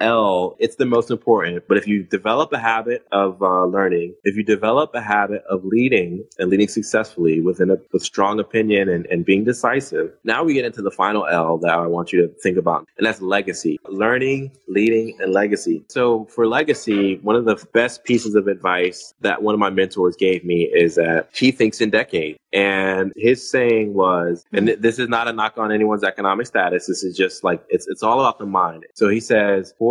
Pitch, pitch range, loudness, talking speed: 105 Hz, 95-115 Hz, -19 LUFS, 210 wpm